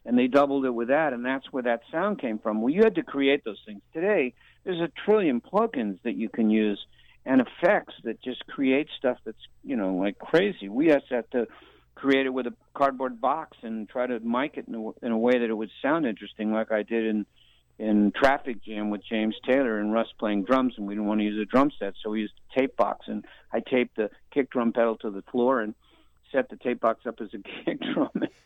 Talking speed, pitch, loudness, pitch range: 240 wpm, 120 Hz, -27 LUFS, 110-135 Hz